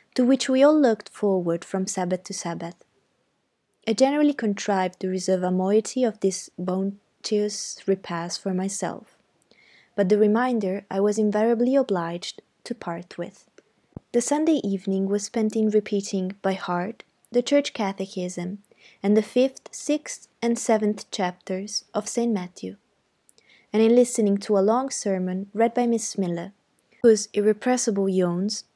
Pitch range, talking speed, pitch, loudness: 190-230 Hz, 145 wpm, 205 Hz, -24 LUFS